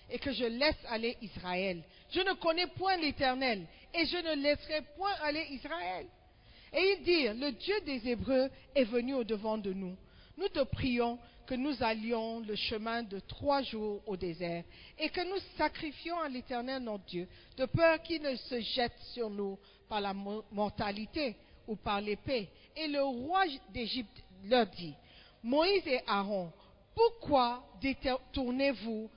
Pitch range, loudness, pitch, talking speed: 215-295 Hz, -34 LUFS, 250 Hz, 155 wpm